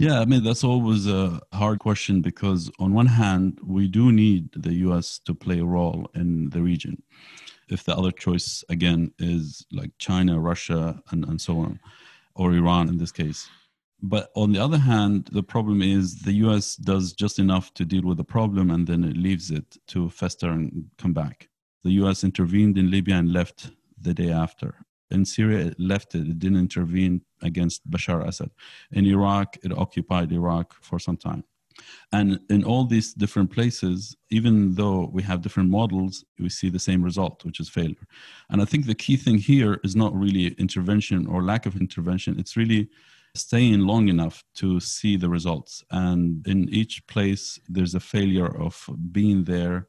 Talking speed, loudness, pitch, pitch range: 185 wpm, -23 LUFS, 95 Hz, 90-105 Hz